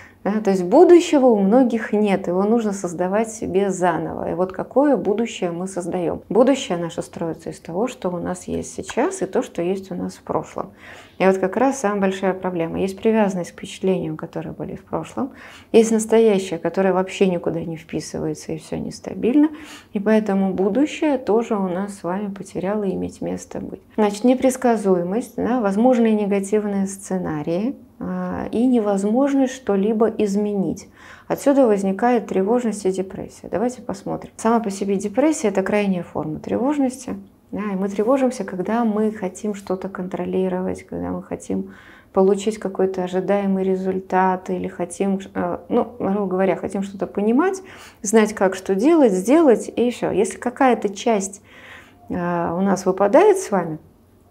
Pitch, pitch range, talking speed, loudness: 200 Hz, 185-230 Hz, 150 wpm, -20 LUFS